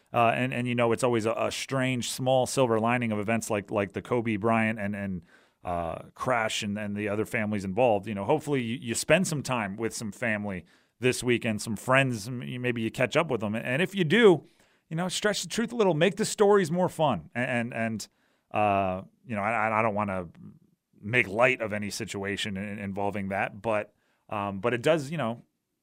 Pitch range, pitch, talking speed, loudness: 105-130 Hz, 115 Hz, 210 wpm, -27 LUFS